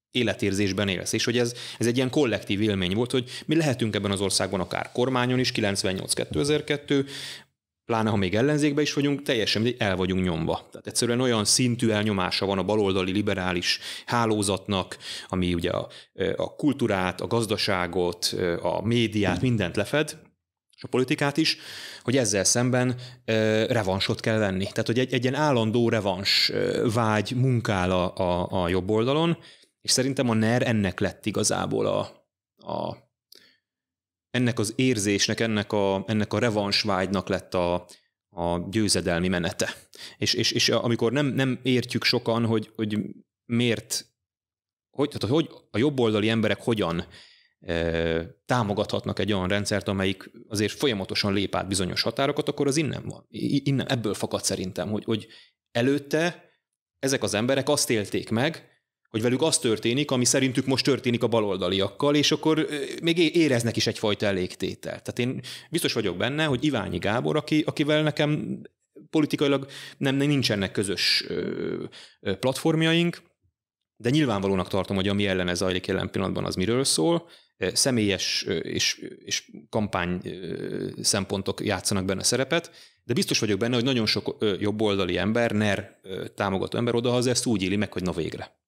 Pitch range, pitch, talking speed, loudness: 100-130 Hz, 110 Hz, 145 wpm, -25 LUFS